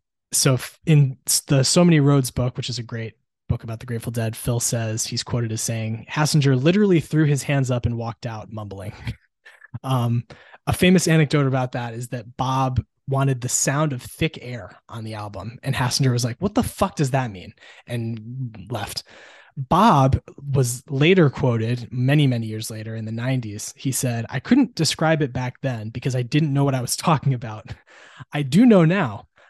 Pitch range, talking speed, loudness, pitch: 115-145 Hz, 190 wpm, -21 LUFS, 125 Hz